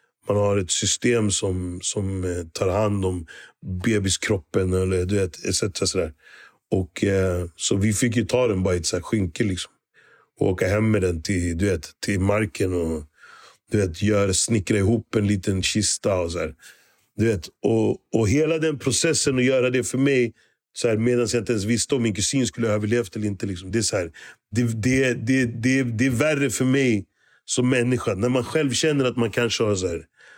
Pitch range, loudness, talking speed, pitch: 95-125 Hz, -23 LUFS, 180 wpm, 110 Hz